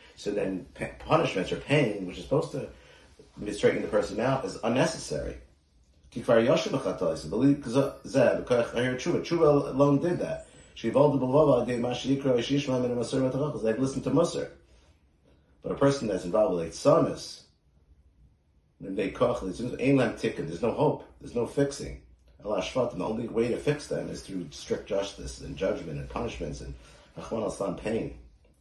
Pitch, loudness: 115 Hz, -28 LUFS